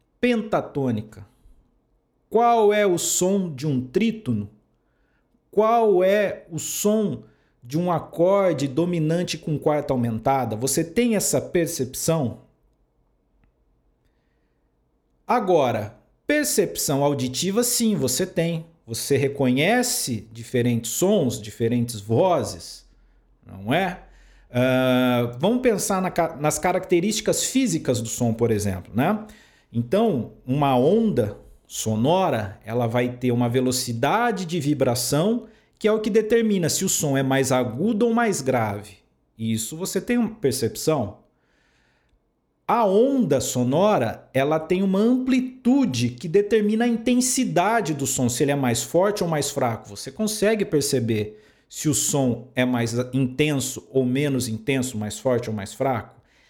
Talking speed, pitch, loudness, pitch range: 125 wpm, 145 Hz, -22 LUFS, 120-200 Hz